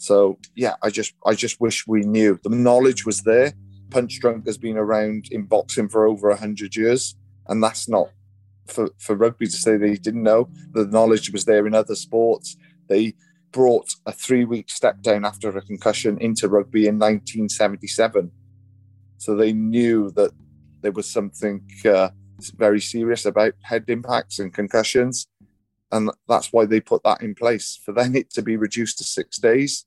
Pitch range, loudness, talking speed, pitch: 100-115 Hz, -20 LUFS, 175 wpm, 110 Hz